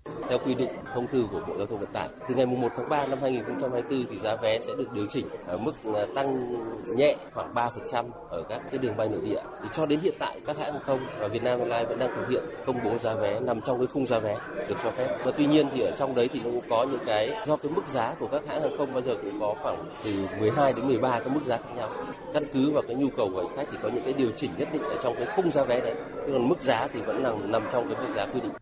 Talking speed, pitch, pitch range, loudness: 290 wpm, 125 Hz, 120-140 Hz, -28 LUFS